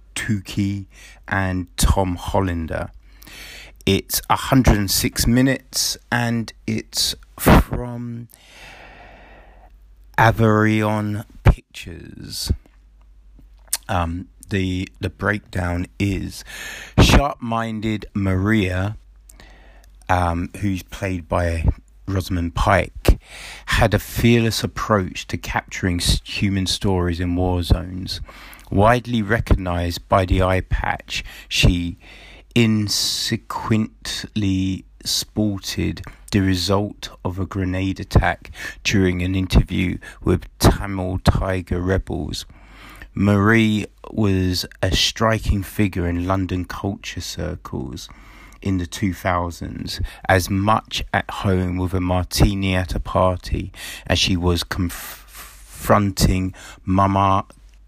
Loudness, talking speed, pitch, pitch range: -21 LUFS, 90 wpm, 95 Hz, 90-105 Hz